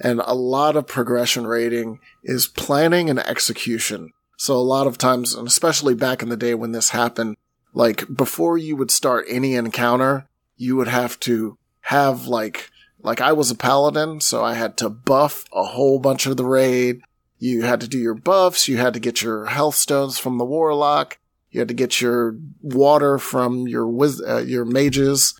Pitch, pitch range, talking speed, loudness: 125 Hz, 120-140 Hz, 190 wpm, -19 LUFS